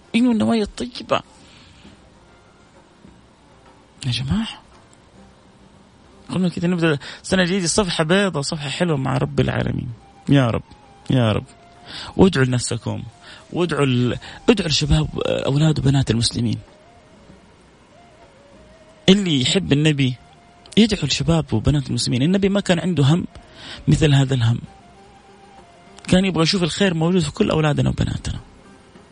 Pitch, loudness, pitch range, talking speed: 155 Hz, -19 LUFS, 130-185 Hz, 110 wpm